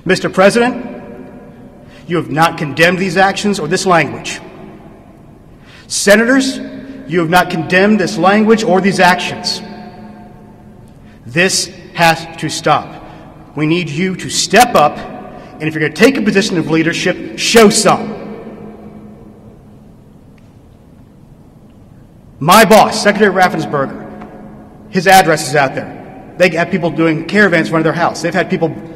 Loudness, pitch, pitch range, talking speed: -12 LUFS, 180 Hz, 165-195 Hz, 135 wpm